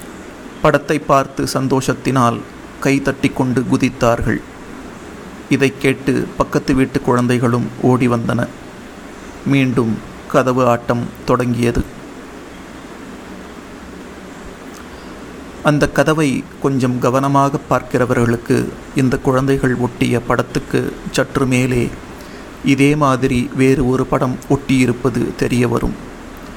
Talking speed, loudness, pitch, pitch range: 80 wpm, -16 LUFS, 130 Hz, 125-140 Hz